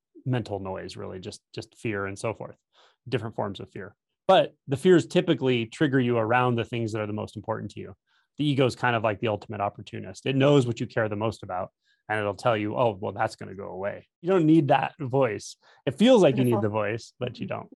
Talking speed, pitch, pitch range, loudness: 245 wpm, 115 Hz, 105-135 Hz, -26 LUFS